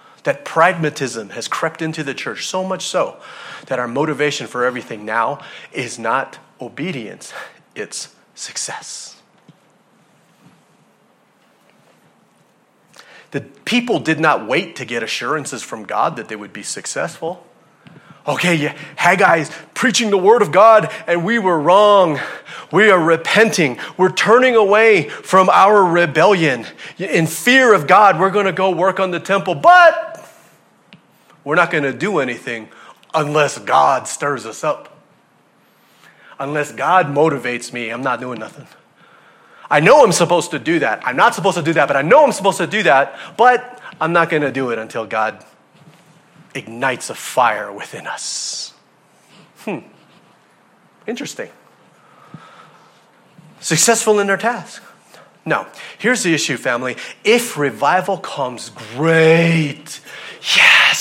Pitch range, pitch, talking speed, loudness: 150-205 Hz, 170 Hz, 140 wpm, -15 LUFS